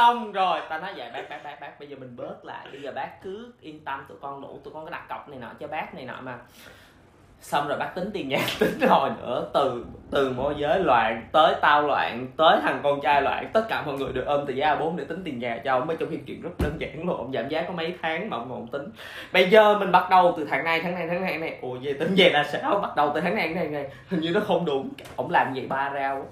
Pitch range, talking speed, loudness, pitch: 140-180 Hz, 300 wpm, -24 LUFS, 155 Hz